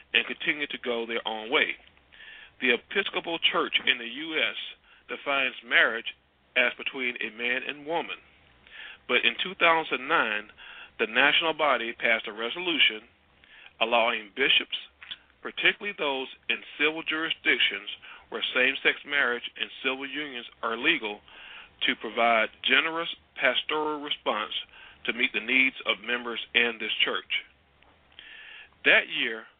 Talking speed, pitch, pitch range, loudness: 125 wpm, 130 Hz, 115-155 Hz, -26 LUFS